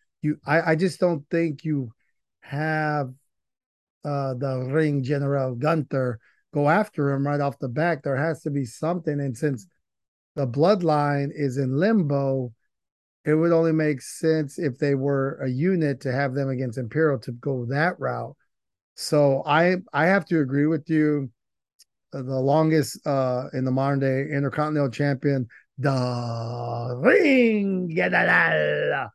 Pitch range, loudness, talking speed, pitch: 135-160 Hz, -23 LUFS, 145 wpm, 145 Hz